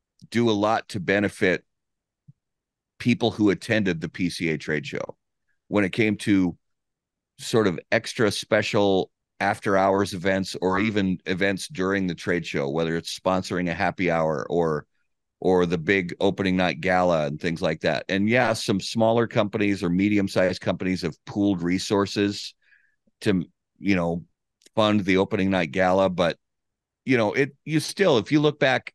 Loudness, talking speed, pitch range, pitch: -24 LUFS, 160 wpm, 90-105 Hz, 95 Hz